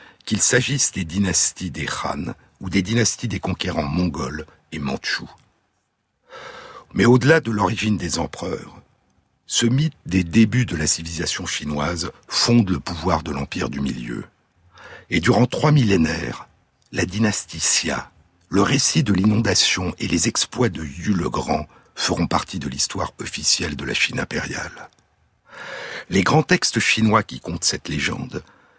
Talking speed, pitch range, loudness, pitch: 145 wpm, 85-115 Hz, -20 LUFS, 95 Hz